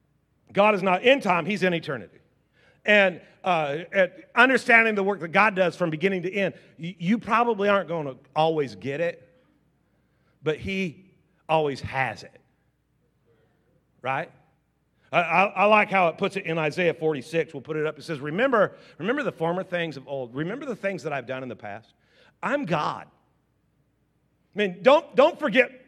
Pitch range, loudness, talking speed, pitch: 155-205 Hz, -24 LUFS, 175 wpm, 175 Hz